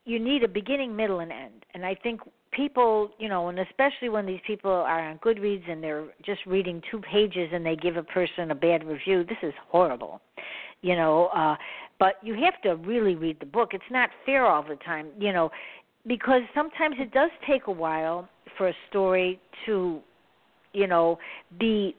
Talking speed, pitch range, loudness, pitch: 195 wpm, 170-230 Hz, -26 LUFS, 190 Hz